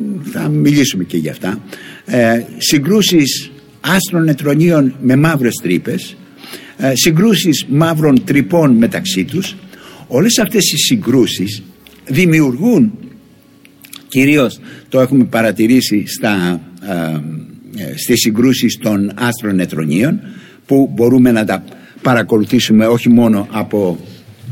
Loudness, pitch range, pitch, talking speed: -13 LUFS, 115-165 Hz, 130 Hz, 100 wpm